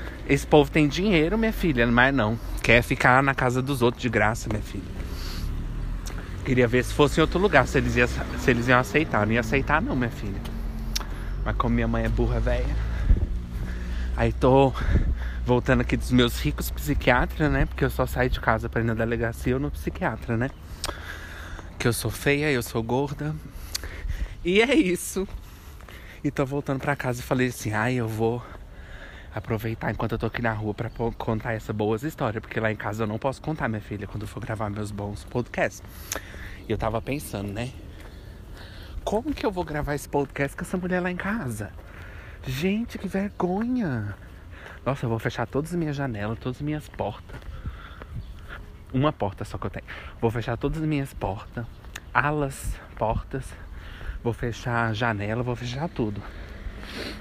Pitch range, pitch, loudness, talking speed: 95-135 Hz, 115 Hz, -26 LUFS, 180 wpm